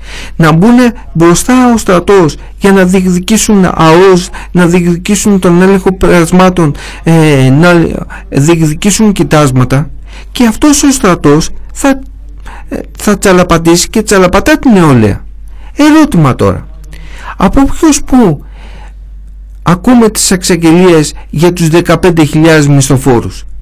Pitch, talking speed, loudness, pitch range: 175 Hz, 100 wpm, -6 LUFS, 155-205 Hz